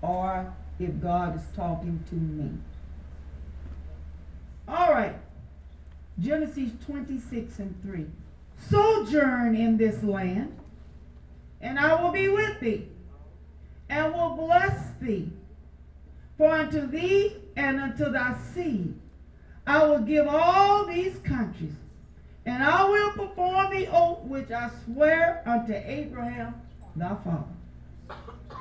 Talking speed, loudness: 110 wpm, -26 LUFS